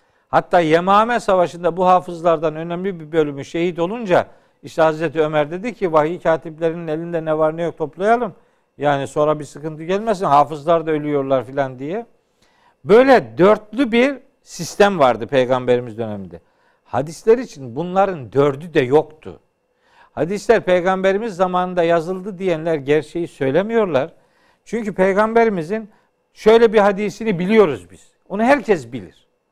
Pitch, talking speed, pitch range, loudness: 170 Hz, 130 wpm, 155-210 Hz, -18 LUFS